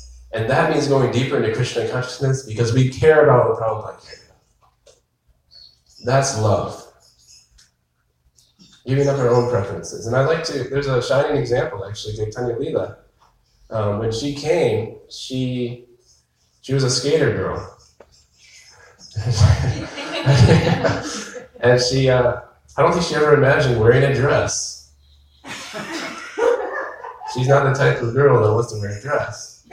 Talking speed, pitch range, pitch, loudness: 135 wpm, 100-135 Hz, 120 Hz, -19 LUFS